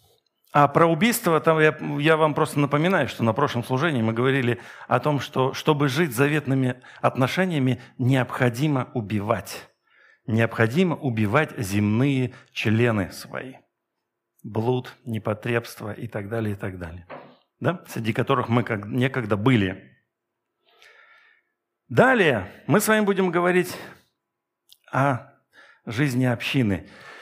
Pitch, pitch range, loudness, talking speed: 130 Hz, 115-155 Hz, -23 LUFS, 115 wpm